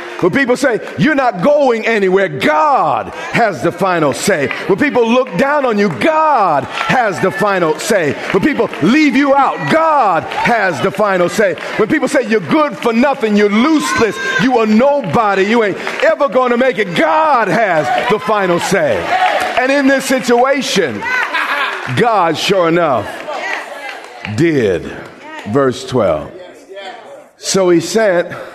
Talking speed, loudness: 145 wpm, -13 LUFS